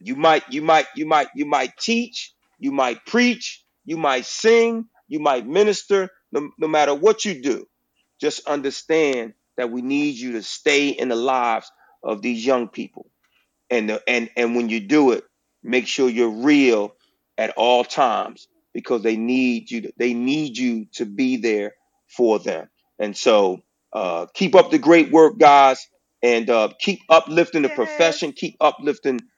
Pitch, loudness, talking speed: 150 Hz, -19 LUFS, 170 wpm